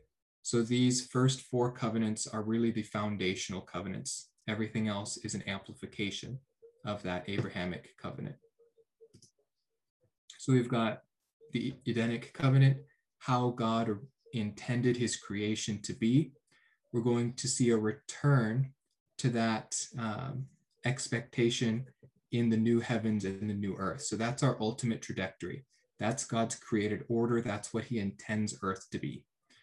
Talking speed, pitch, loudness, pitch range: 135 wpm, 115 Hz, -33 LUFS, 110-130 Hz